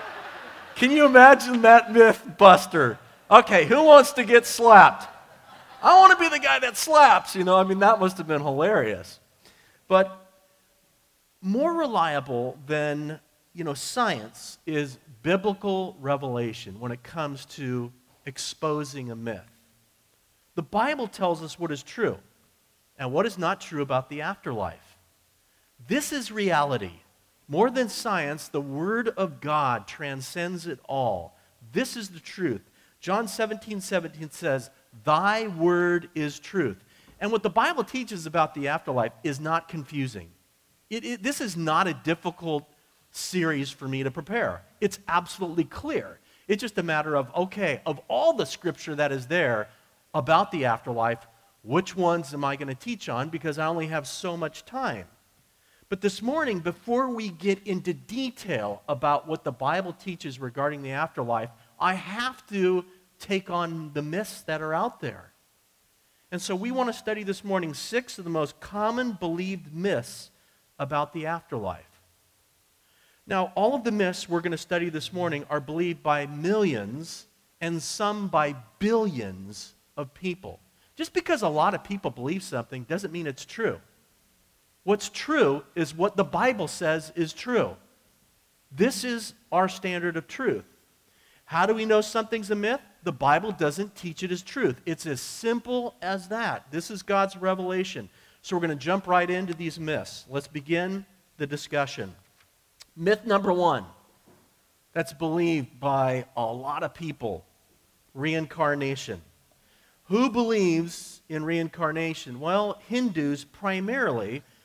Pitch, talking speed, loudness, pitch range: 170 Hz, 150 wpm, -25 LUFS, 145-200 Hz